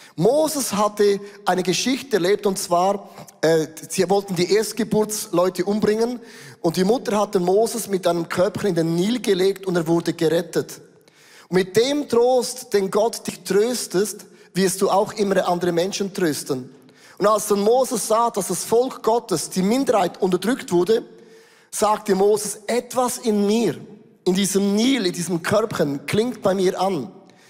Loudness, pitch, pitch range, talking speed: -21 LUFS, 200 Hz, 180-220 Hz, 155 wpm